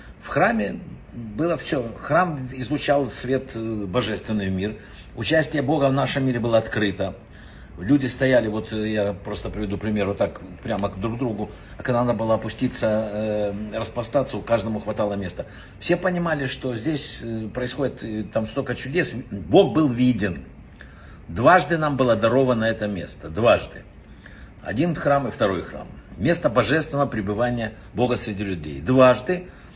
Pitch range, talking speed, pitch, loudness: 105-130 Hz, 140 wpm, 115 Hz, -23 LUFS